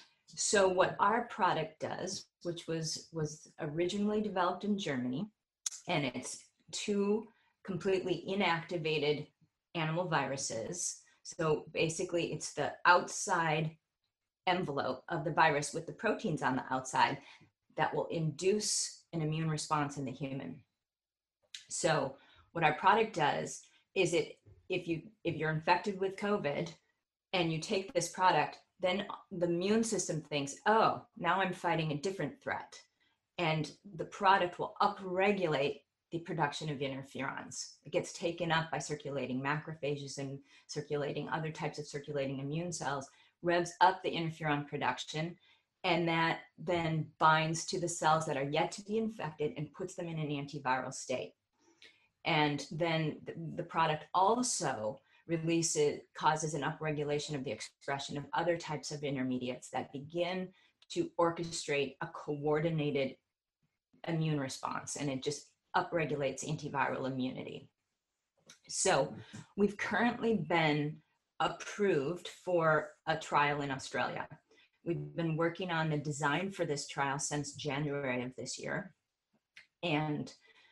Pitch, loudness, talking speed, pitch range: 160 Hz, -34 LUFS, 135 wpm, 145-180 Hz